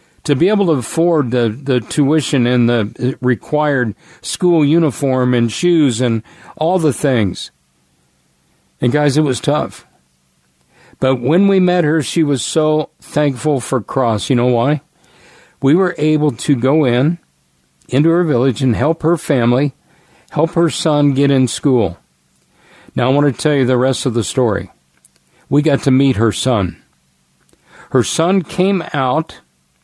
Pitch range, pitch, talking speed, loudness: 115-155 Hz, 135 Hz, 155 wpm, -15 LUFS